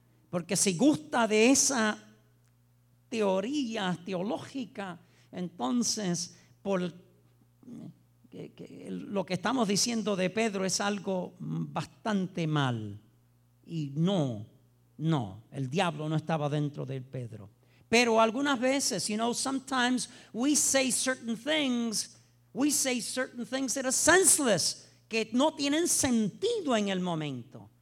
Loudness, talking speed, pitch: -29 LUFS, 120 wpm, 195 Hz